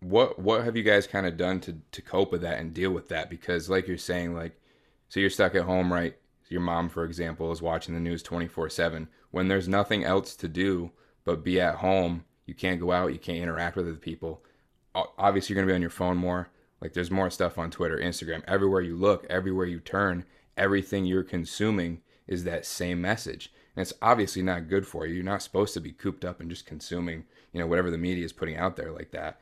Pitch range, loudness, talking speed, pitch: 85-95 Hz, -29 LUFS, 235 wpm, 90 Hz